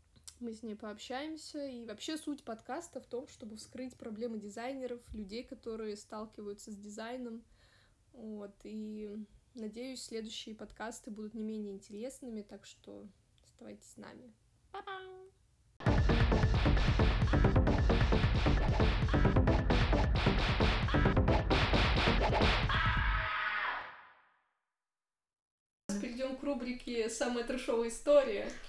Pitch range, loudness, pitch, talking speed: 215-255 Hz, -34 LUFS, 230 Hz, 80 wpm